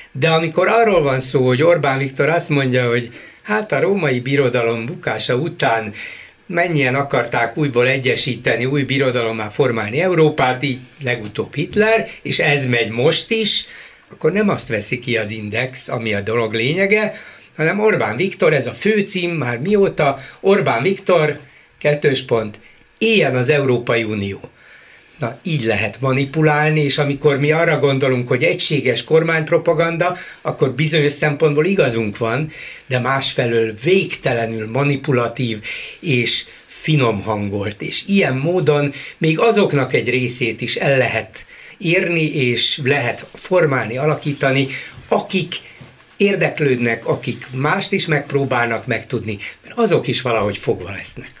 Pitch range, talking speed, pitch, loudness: 120-165 Hz, 130 wpm, 140 Hz, -17 LUFS